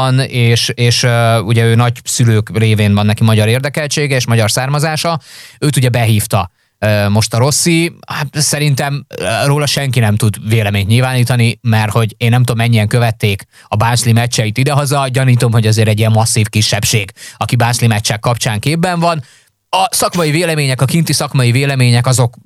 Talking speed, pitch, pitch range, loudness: 165 wpm, 120 Hz, 110-140 Hz, -12 LUFS